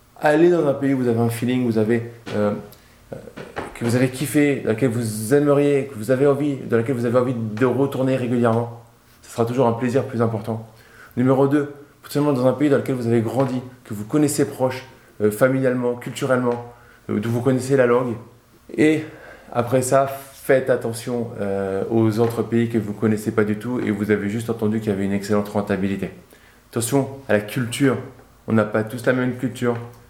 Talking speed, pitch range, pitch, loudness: 205 wpm, 115-135 Hz, 120 Hz, -21 LUFS